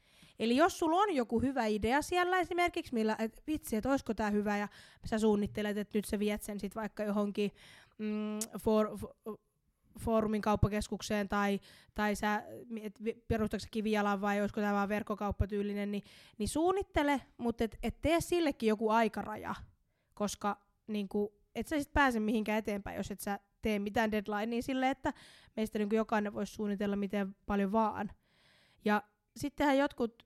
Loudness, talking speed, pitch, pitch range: -34 LUFS, 155 wpm, 215 Hz, 205-235 Hz